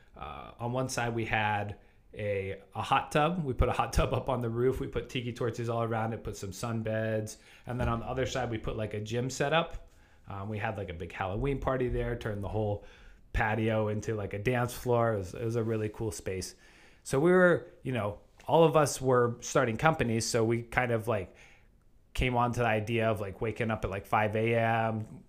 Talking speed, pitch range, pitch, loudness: 235 wpm, 105-125 Hz, 115 Hz, -31 LUFS